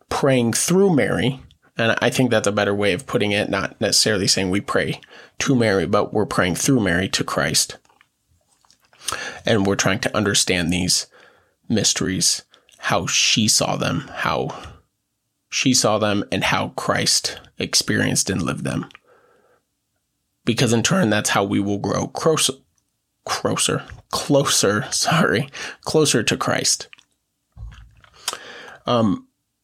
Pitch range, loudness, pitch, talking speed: 100-130 Hz, -19 LUFS, 115 Hz, 135 wpm